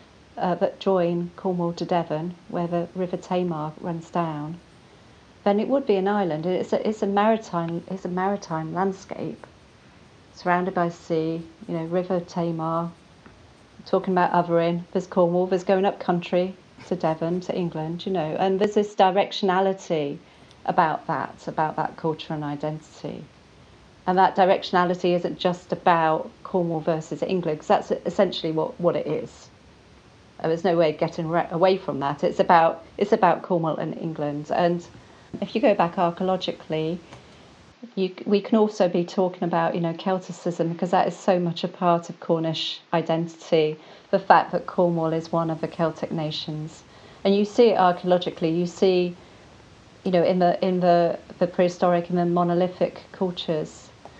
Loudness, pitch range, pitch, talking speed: -24 LUFS, 165-185 Hz, 175 Hz, 160 wpm